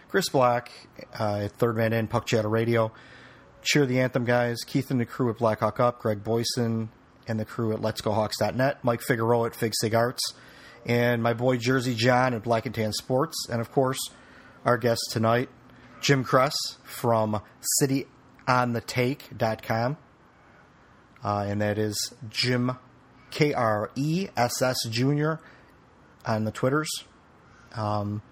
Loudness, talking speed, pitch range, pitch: -26 LUFS, 140 wpm, 110-130 Hz, 120 Hz